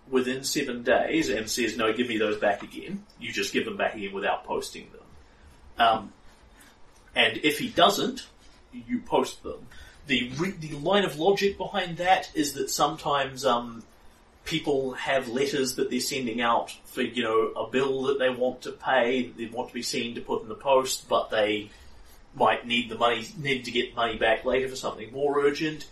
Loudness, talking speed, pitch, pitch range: -26 LUFS, 195 wpm, 130 Hz, 120-160 Hz